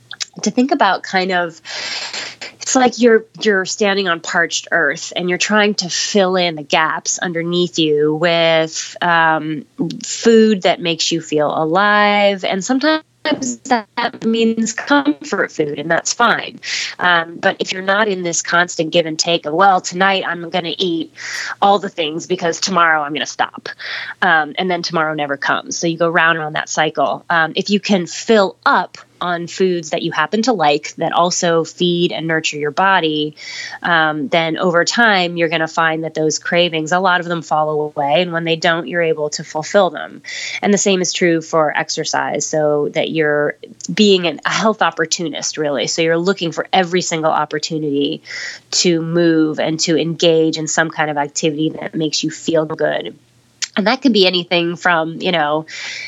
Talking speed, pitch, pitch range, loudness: 185 wpm, 170 Hz, 160-195 Hz, -16 LUFS